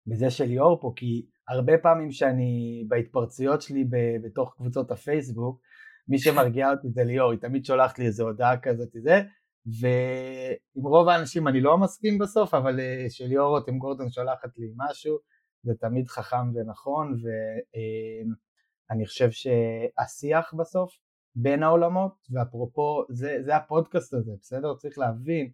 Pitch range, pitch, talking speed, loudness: 120-150 Hz, 130 Hz, 145 wpm, -26 LUFS